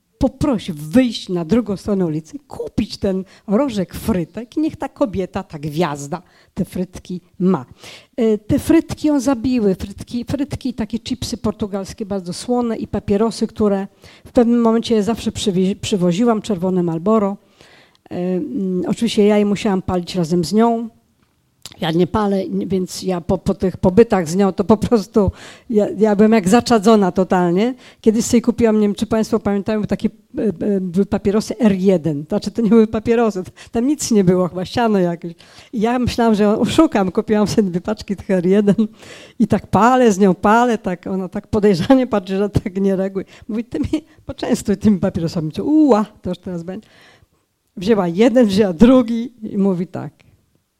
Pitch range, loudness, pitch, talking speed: 190-230 Hz, -17 LUFS, 210 Hz, 165 wpm